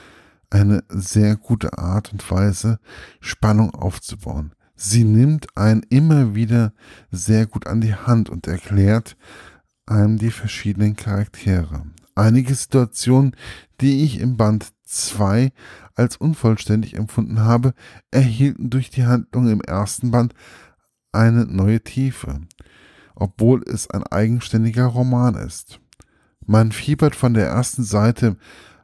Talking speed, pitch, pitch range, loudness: 120 wpm, 110 Hz, 100-125 Hz, -18 LUFS